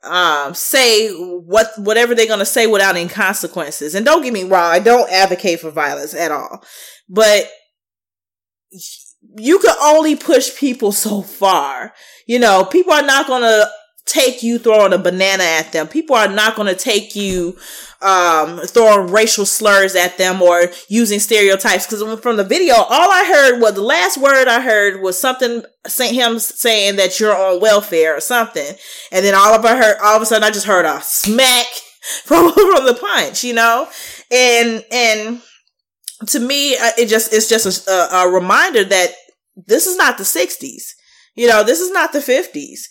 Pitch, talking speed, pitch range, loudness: 220 Hz, 180 wpm, 190-250 Hz, -13 LUFS